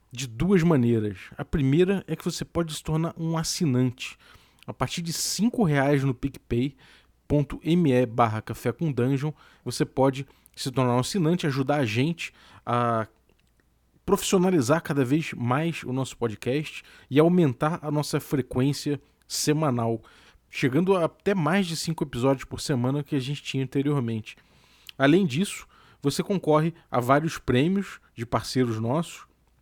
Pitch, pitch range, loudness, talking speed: 145 Hz, 125-165 Hz, -25 LUFS, 140 wpm